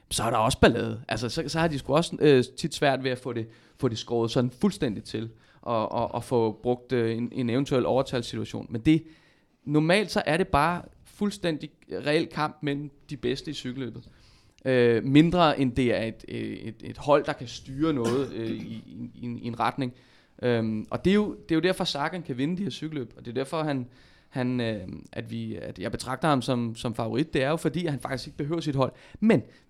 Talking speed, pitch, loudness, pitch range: 230 wpm, 130 Hz, -27 LUFS, 120-155 Hz